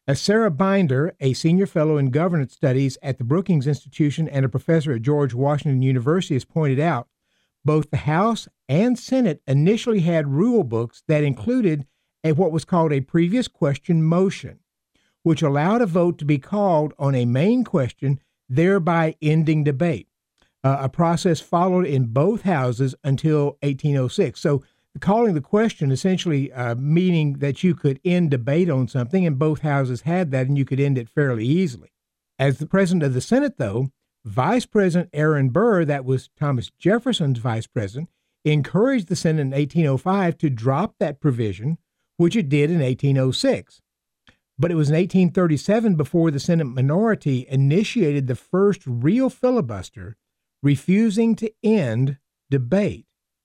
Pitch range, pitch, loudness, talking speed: 135-180 Hz, 155 Hz, -21 LUFS, 155 wpm